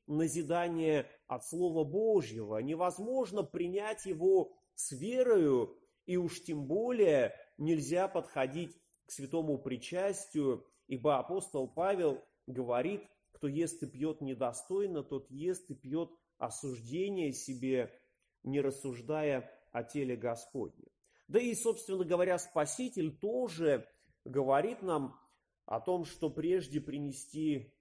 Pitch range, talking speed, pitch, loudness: 140-190 Hz, 110 wpm, 160 Hz, -35 LUFS